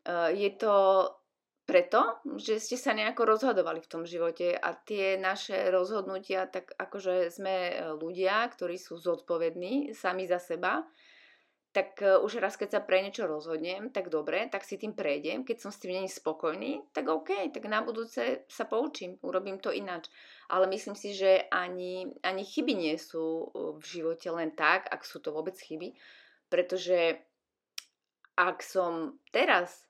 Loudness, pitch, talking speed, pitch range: -31 LUFS, 190 Hz, 155 wpm, 175-215 Hz